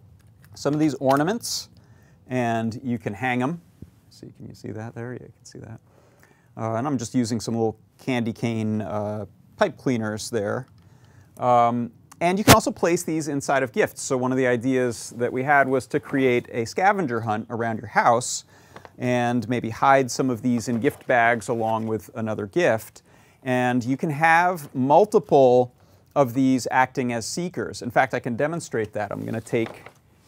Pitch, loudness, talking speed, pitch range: 125 Hz, -23 LUFS, 185 wpm, 115-135 Hz